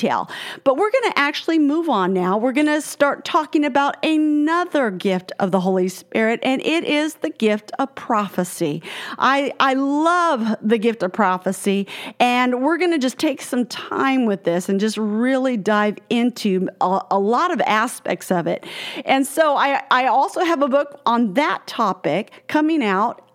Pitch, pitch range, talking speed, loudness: 260 Hz, 210-300 Hz, 170 wpm, -19 LUFS